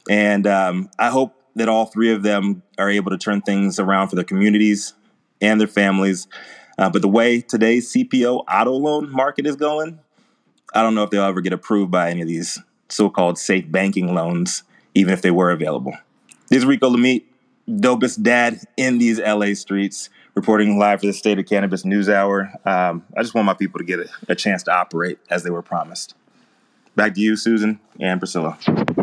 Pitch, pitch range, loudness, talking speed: 105 Hz, 95-115 Hz, -18 LUFS, 195 wpm